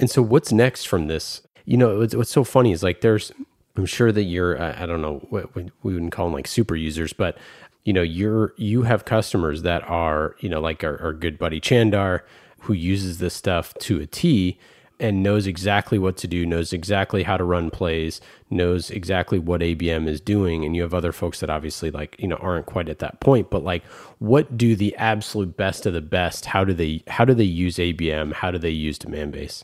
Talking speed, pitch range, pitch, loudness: 225 wpm, 85-105 Hz, 90 Hz, -22 LUFS